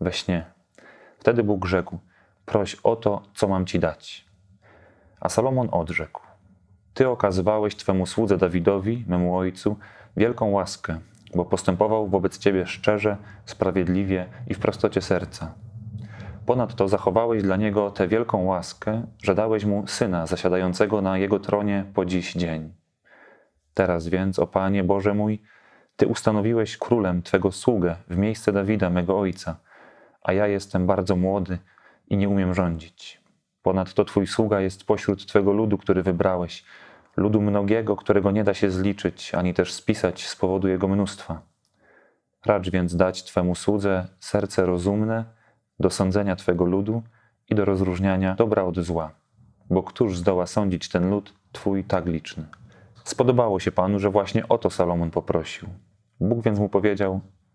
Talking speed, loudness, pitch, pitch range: 145 wpm, -24 LUFS, 100 Hz, 95-105 Hz